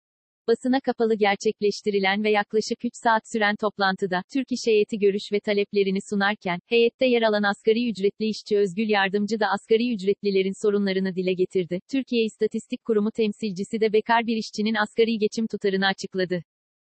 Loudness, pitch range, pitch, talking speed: -24 LUFS, 200-225 Hz, 210 Hz, 150 wpm